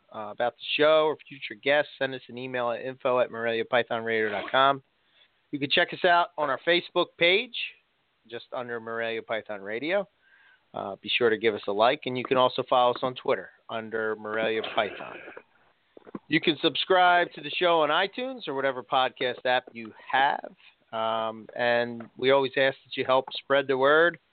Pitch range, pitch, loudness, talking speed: 120-160 Hz, 130 Hz, -26 LUFS, 180 wpm